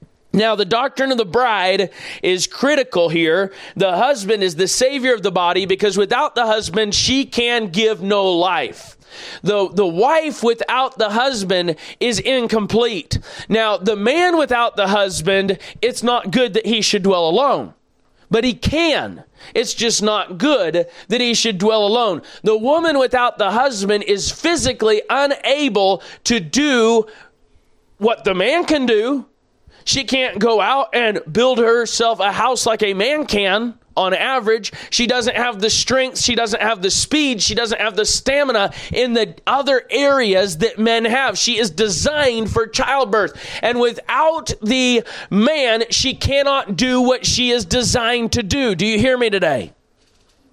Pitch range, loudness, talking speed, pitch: 205-255 Hz, -16 LUFS, 160 wpm, 230 Hz